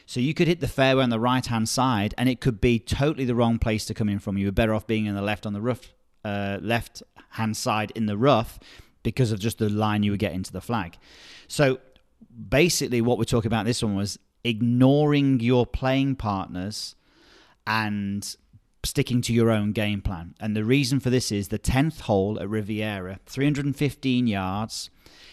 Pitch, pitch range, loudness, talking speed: 115 Hz, 105-130 Hz, -25 LUFS, 200 wpm